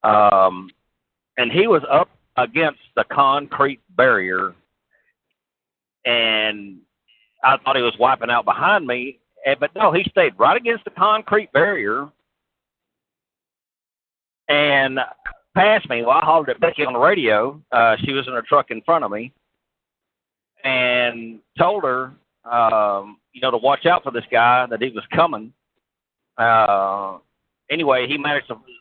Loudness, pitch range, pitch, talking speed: -18 LUFS, 110-150 Hz, 130 Hz, 145 wpm